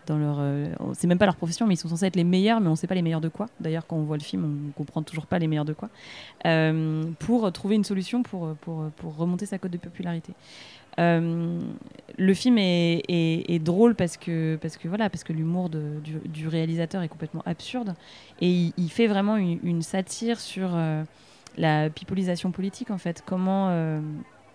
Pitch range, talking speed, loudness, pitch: 160-190 Hz, 220 wpm, -26 LUFS, 170 Hz